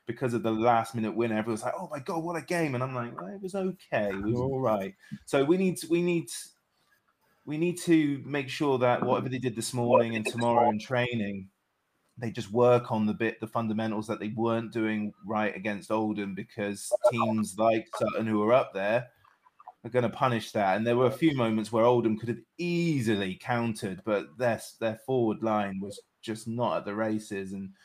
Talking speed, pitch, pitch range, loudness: 205 wpm, 115 Hz, 110-130 Hz, -29 LUFS